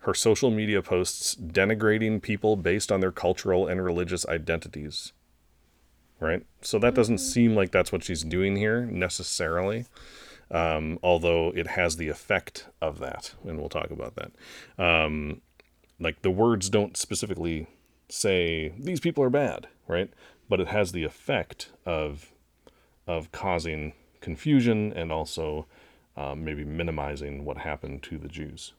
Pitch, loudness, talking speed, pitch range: 85 Hz, -27 LUFS, 145 wpm, 75-100 Hz